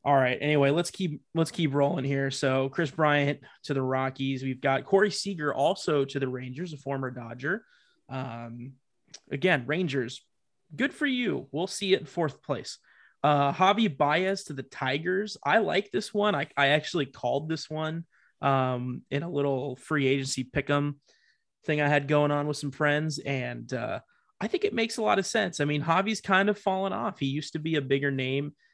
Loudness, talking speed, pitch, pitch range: -28 LUFS, 195 wpm, 145 Hz, 135-180 Hz